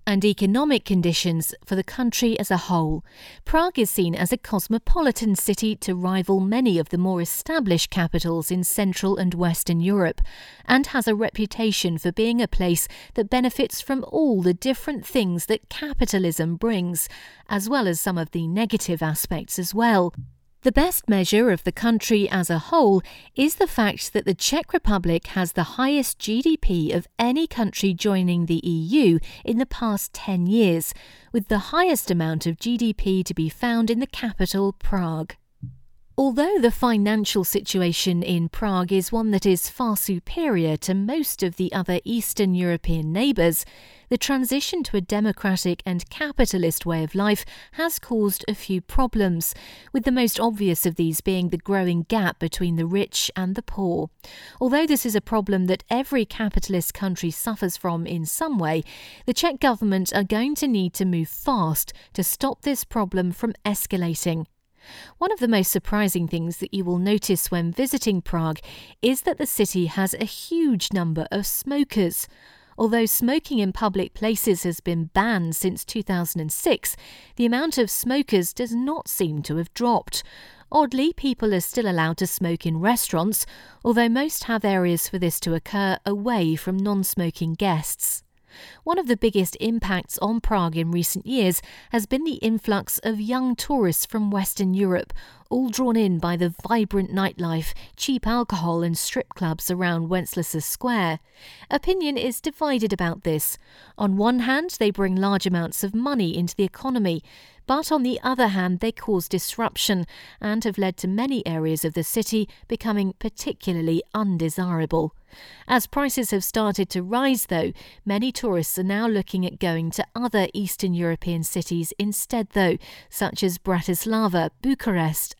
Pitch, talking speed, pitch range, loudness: 200 Hz, 165 wpm, 175-235 Hz, -23 LUFS